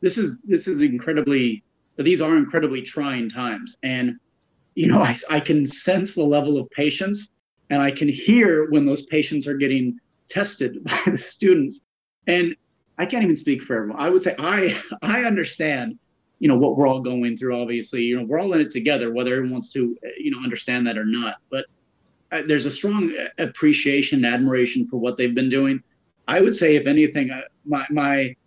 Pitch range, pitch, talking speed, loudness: 125-170 Hz, 140 Hz, 195 wpm, -21 LUFS